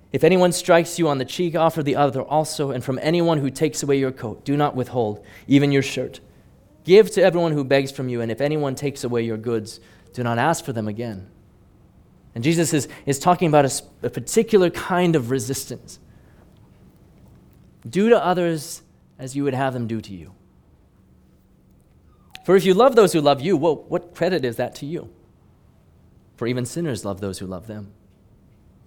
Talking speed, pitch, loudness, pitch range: 190 wpm, 135 Hz, -20 LUFS, 110-165 Hz